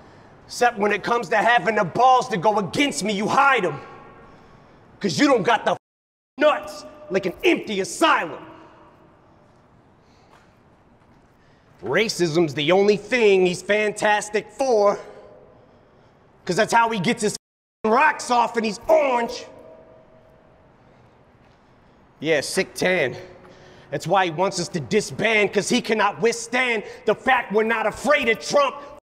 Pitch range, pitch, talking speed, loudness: 200-245 Hz, 220 Hz, 130 wpm, -20 LUFS